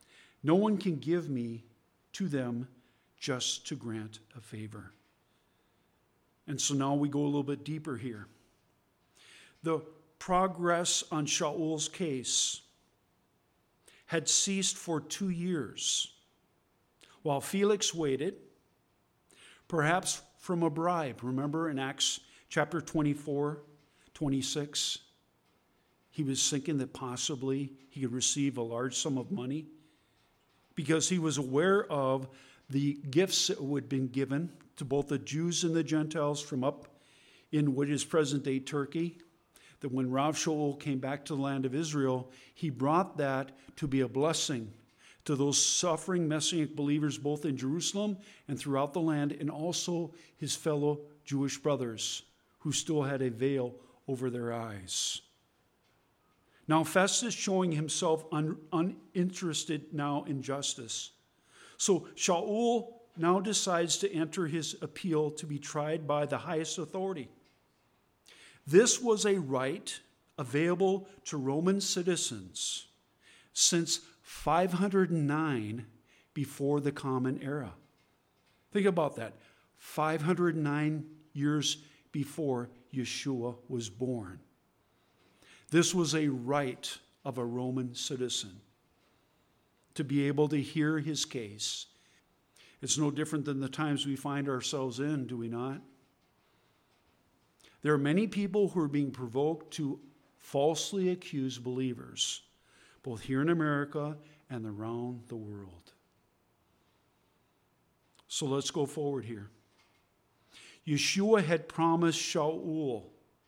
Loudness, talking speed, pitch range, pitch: -32 LUFS, 125 wpm, 130-160 Hz, 145 Hz